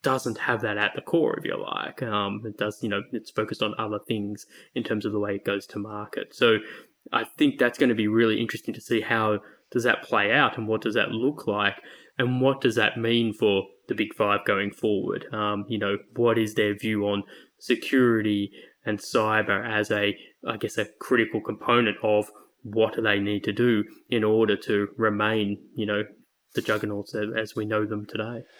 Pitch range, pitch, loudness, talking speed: 105-115 Hz, 110 Hz, -26 LUFS, 205 wpm